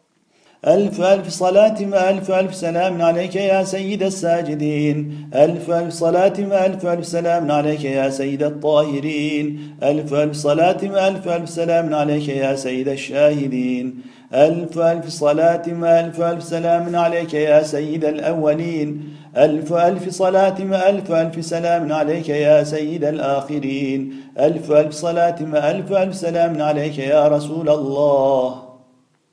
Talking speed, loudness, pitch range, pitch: 125 wpm, -18 LUFS, 150-170 Hz, 155 Hz